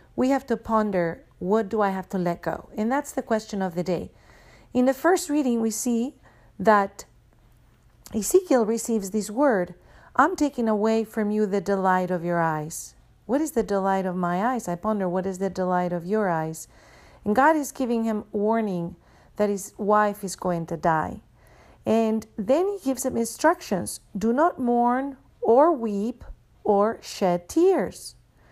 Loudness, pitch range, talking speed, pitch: -24 LUFS, 185-245 Hz, 175 wpm, 215 Hz